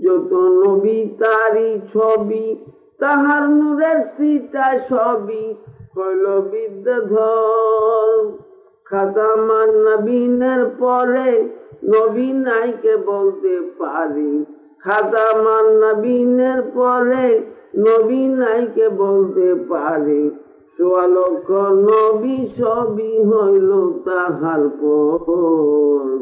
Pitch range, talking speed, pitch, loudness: 200-255 Hz, 80 wpm, 220 Hz, -16 LUFS